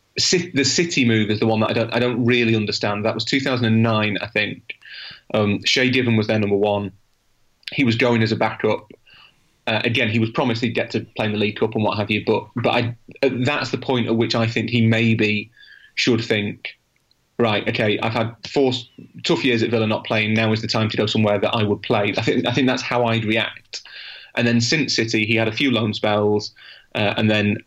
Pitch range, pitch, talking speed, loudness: 110-120 Hz, 115 Hz, 230 wpm, -20 LUFS